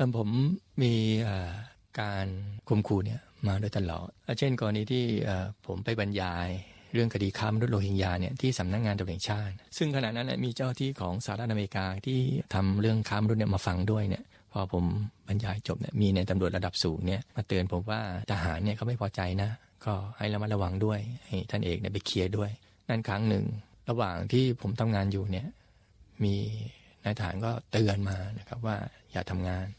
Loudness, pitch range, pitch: -31 LUFS, 95-110 Hz, 105 Hz